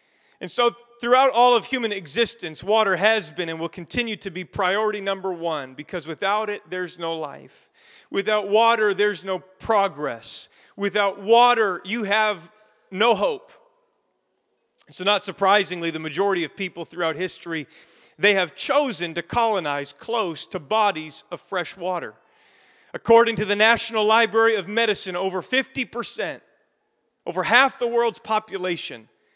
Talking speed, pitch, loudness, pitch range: 140 wpm, 200 Hz, -22 LUFS, 175-230 Hz